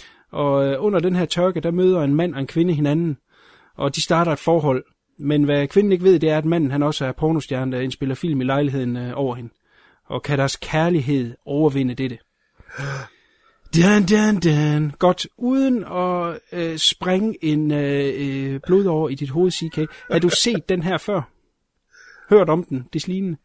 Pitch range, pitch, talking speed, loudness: 140-180 Hz, 155 Hz, 180 wpm, -20 LUFS